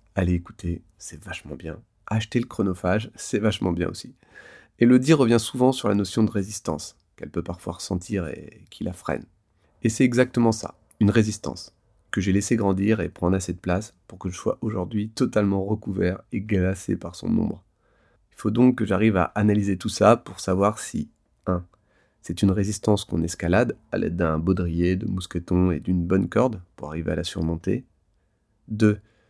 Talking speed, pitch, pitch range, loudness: 190 wpm, 95 Hz, 90-110 Hz, -24 LUFS